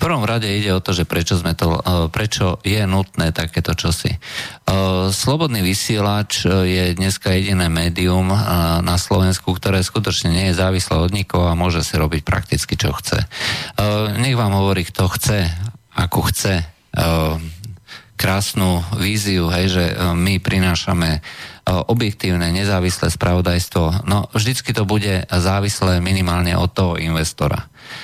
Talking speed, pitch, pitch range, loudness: 130 wpm, 95 Hz, 85-100 Hz, -18 LUFS